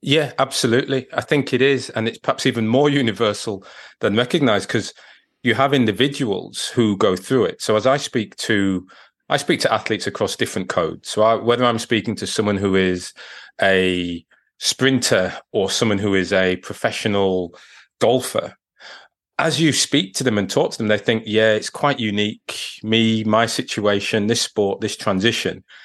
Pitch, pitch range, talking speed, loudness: 110 Hz, 100-125 Hz, 170 wpm, -19 LUFS